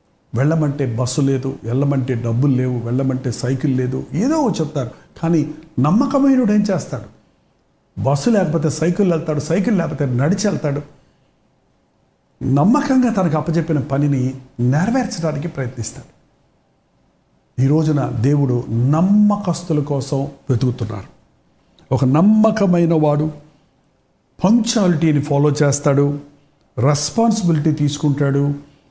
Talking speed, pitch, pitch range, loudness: 85 wpm, 145 Hz, 135-170 Hz, -17 LUFS